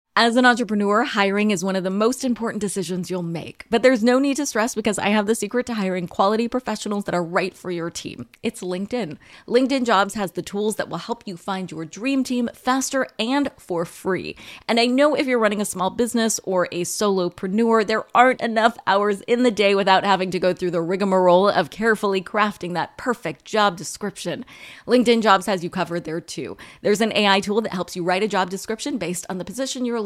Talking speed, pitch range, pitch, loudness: 220 wpm, 185-230 Hz, 205 Hz, -21 LUFS